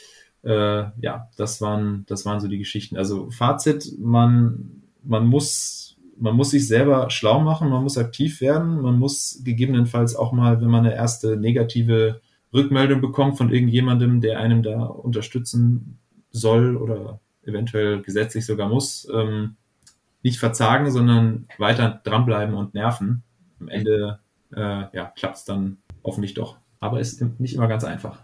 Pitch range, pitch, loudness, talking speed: 105-125 Hz, 115 Hz, -21 LUFS, 150 wpm